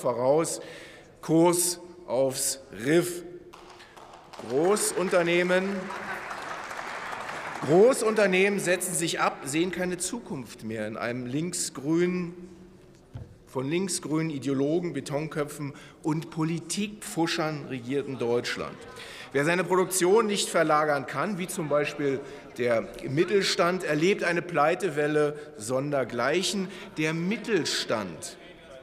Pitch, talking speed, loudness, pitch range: 170 Hz, 85 wpm, -27 LUFS, 145-180 Hz